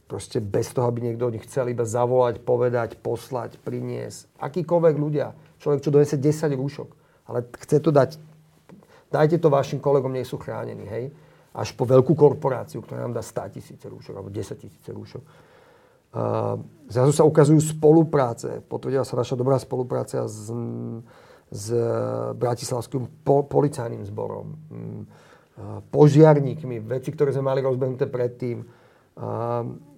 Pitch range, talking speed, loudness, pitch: 120-150 Hz, 135 wpm, -23 LUFS, 130 Hz